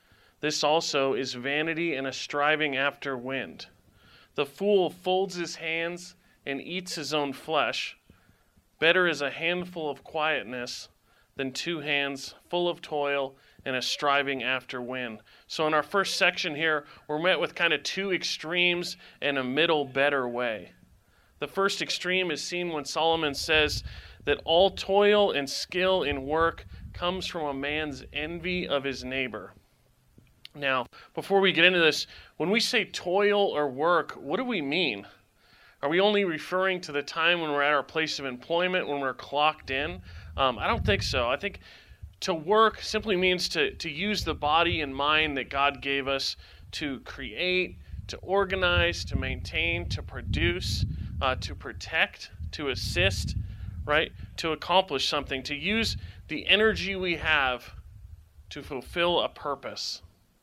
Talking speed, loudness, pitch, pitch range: 160 wpm, -27 LUFS, 150 Hz, 130-175 Hz